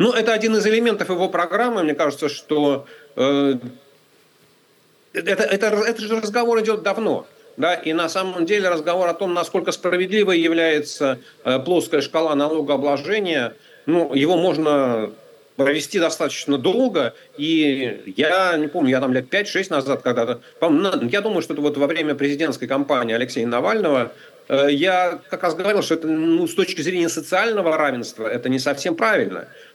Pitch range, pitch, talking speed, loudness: 145-195 Hz, 165 Hz, 155 wpm, -20 LUFS